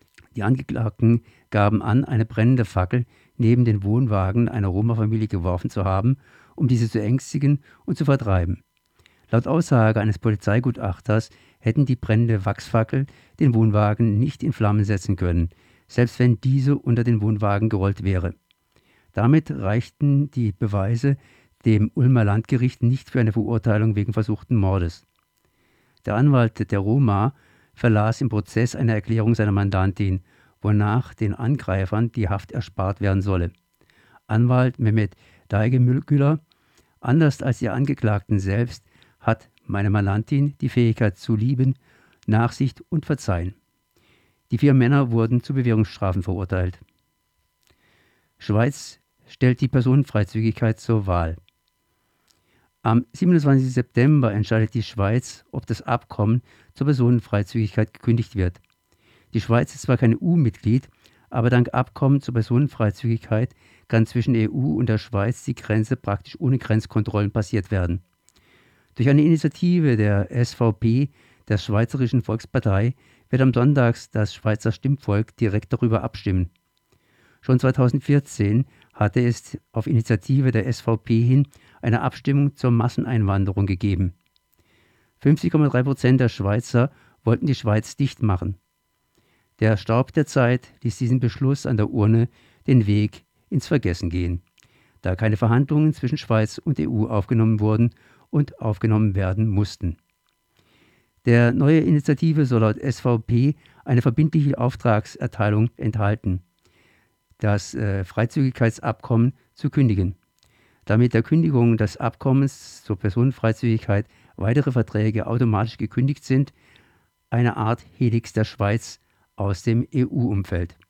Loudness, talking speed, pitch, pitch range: -22 LUFS, 125 wpm, 115 Hz, 105-125 Hz